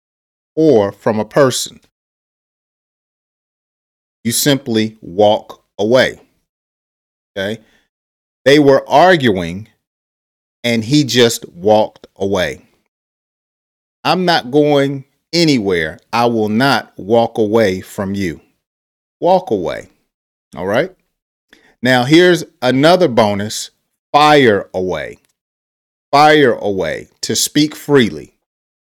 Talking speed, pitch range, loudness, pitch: 90 wpm, 100-145 Hz, -14 LUFS, 115 Hz